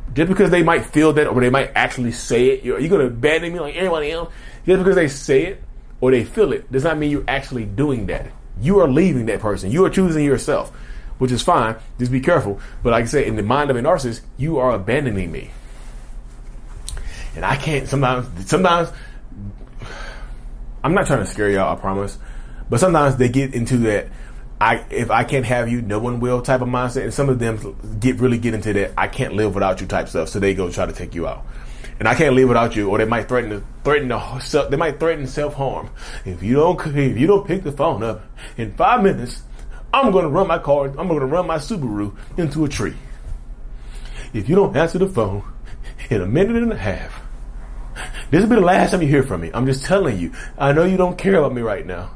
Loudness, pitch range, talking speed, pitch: -18 LUFS, 110-155 Hz, 230 wpm, 130 Hz